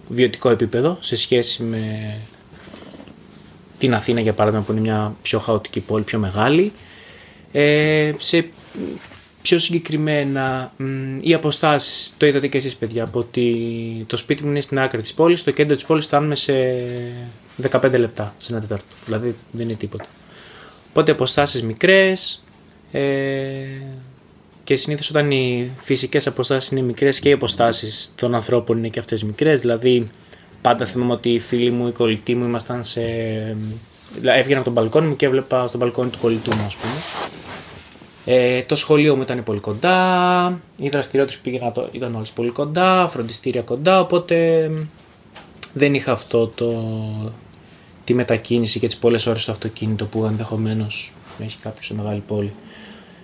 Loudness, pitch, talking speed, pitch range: -19 LUFS, 125 Hz, 155 wpm, 115-145 Hz